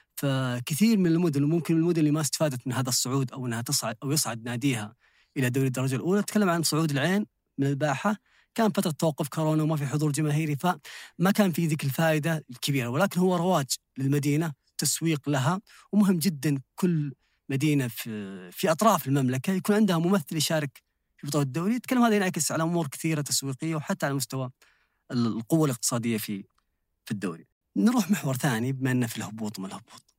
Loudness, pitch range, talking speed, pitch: -27 LUFS, 130-170 Hz, 170 wpm, 150 Hz